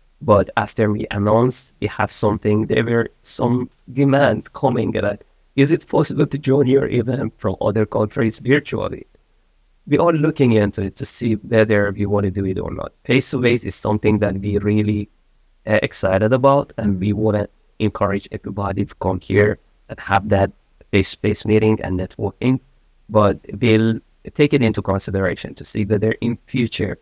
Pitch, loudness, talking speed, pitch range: 110 Hz, -19 LUFS, 175 wpm, 100-125 Hz